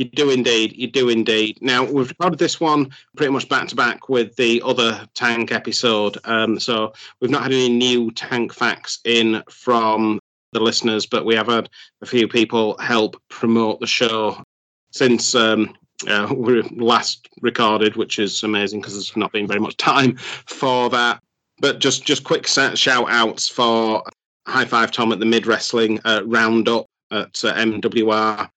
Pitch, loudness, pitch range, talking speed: 115 Hz, -18 LUFS, 110-120 Hz, 170 wpm